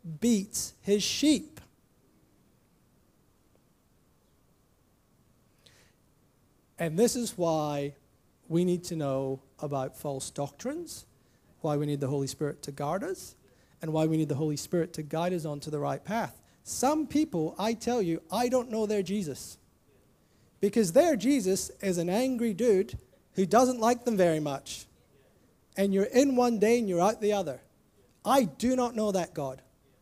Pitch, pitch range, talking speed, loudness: 180 Hz, 145-230 Hz, 150 wpm, -29 LUFS